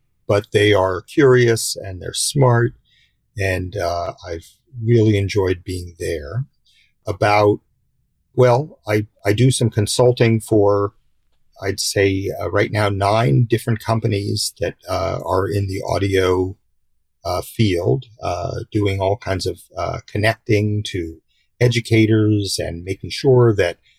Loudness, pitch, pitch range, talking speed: -18 LUFS, 105 Hz, 95-115 Hz, 130 wpm